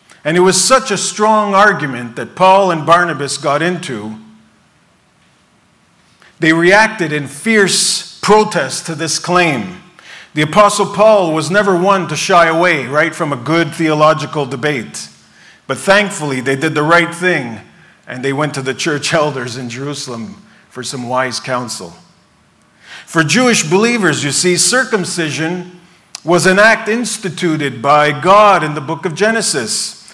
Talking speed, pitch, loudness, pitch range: 145 wpm, 170 Hz, -12 LUFS, 145-195 Hz